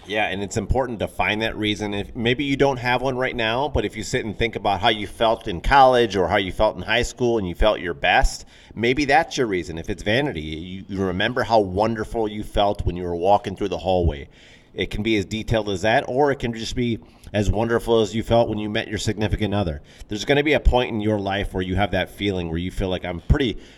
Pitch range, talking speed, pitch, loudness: 95-115 Hz, 260 wpm, 105 Hz, -22 LUFS